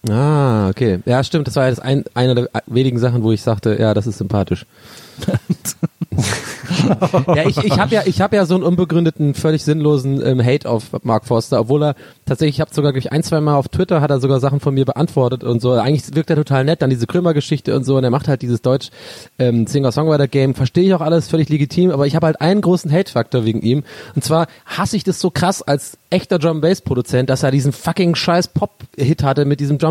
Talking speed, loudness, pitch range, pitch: 240 wpm, -16 LUFS, 125-160 Hz, 140 Hz